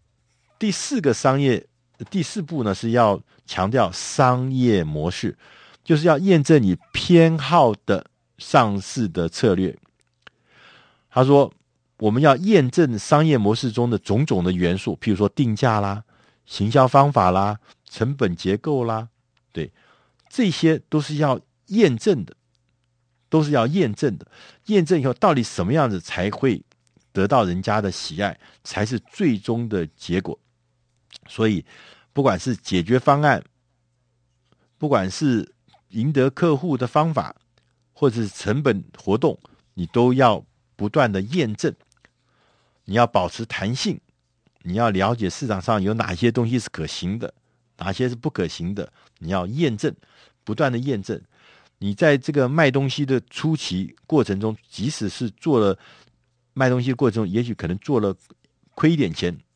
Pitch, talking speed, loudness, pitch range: 120 Hz, 215 characters per minute, -21 LUFS, 100-140 Hz